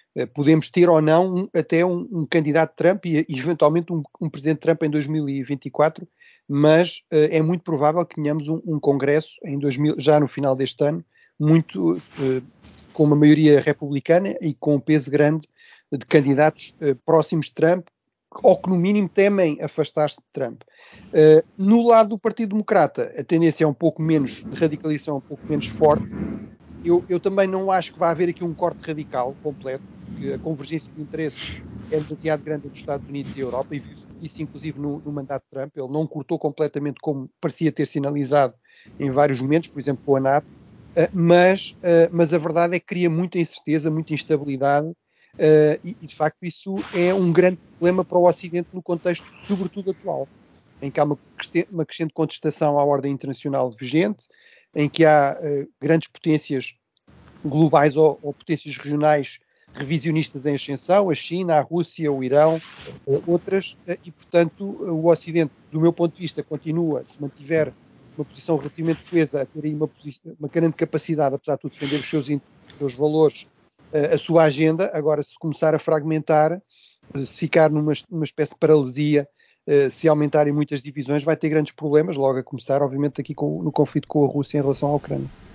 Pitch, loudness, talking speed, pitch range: 155 Hz, -21 LUFS, 180 wpm, 145-170 Hz